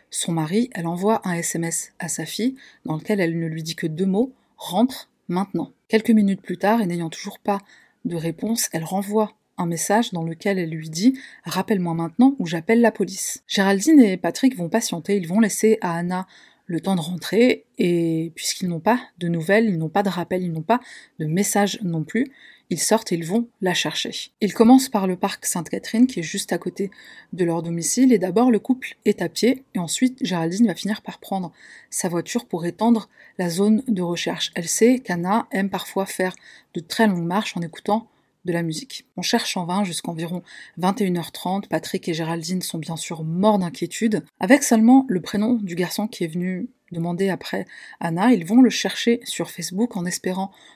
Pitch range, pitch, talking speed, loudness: 170-220 Hz, 195 Hz, 200 wpm, -22 LUFS